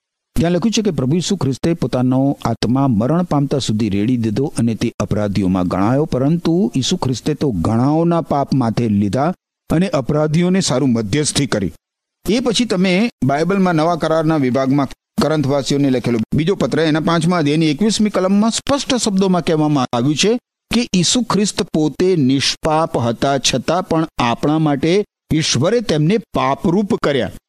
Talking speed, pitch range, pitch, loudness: 145 wpm, 130-180 Hz, 150 Hz, -16 LUFS